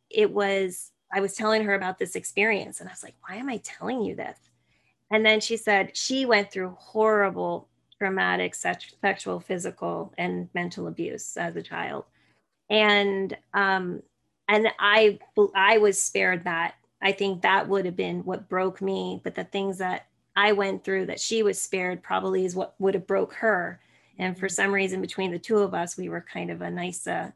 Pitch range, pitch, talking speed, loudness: 180-205 Hz, 195 Hz, 190 wpm, -25 LUFS